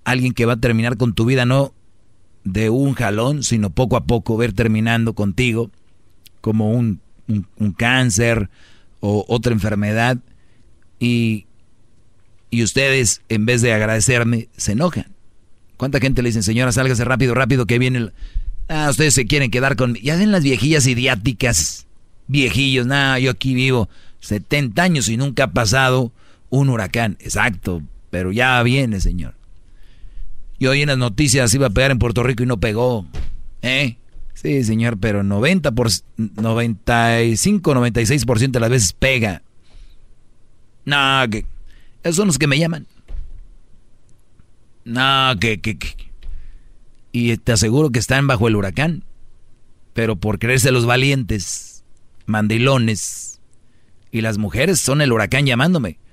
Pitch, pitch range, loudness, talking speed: 115 Hz, 110-130 Hz, -17 LUFS, 150 wpm